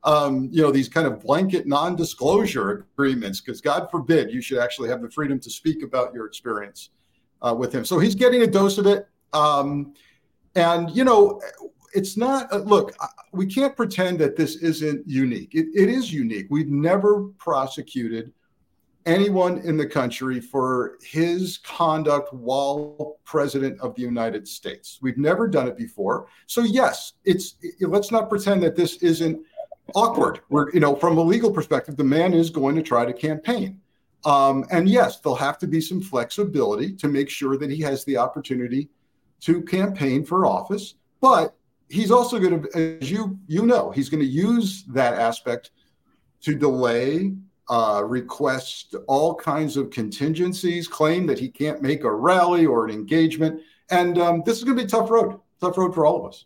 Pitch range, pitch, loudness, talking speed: 140-195 Hz, 160 Hz, -22 LUFS, 180 wpm